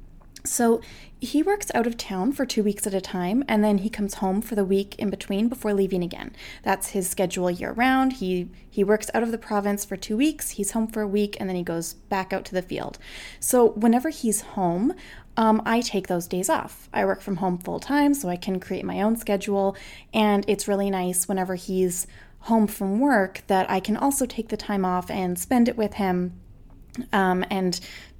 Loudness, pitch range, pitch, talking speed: -24 LUFS, 185-225 Hz, 205 Hz, 215 wpm